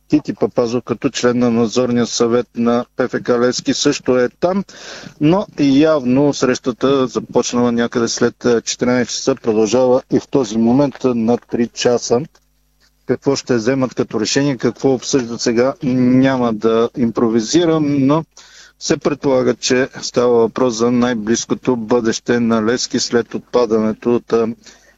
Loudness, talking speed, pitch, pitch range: -16 LUFS, 130 wpm, 125 Hz, 120-135 Hz